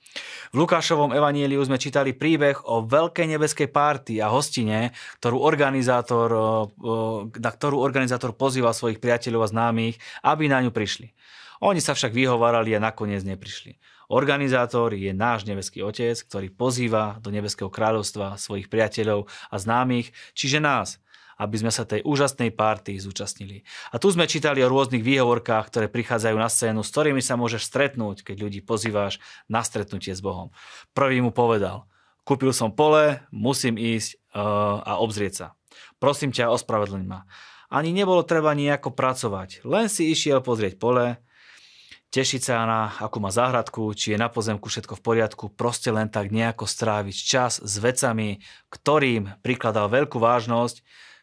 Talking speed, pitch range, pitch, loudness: 150 wpm, 105-135 Hz, 115 Hz, -23 LUFS